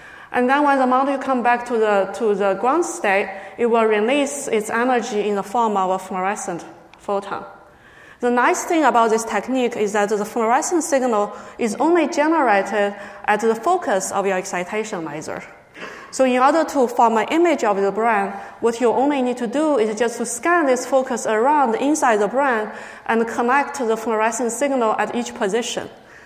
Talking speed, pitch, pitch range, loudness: 185 wpm, 235 Hz, 210-265 Hz, -19 LUFS